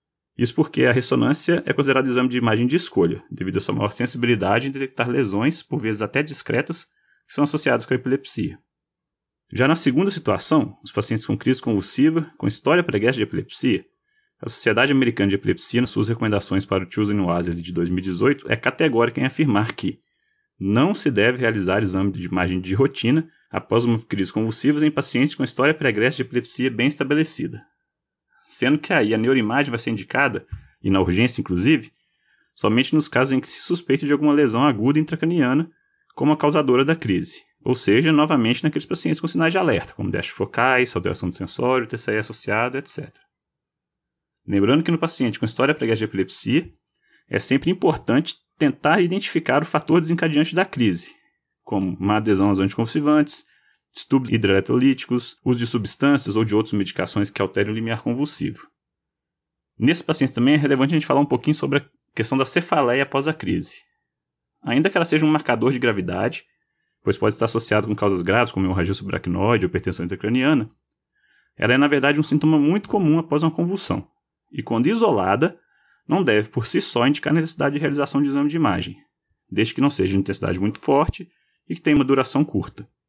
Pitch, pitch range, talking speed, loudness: 125 Hz, 105-150 Hz, 180 wpm, -21 LUFS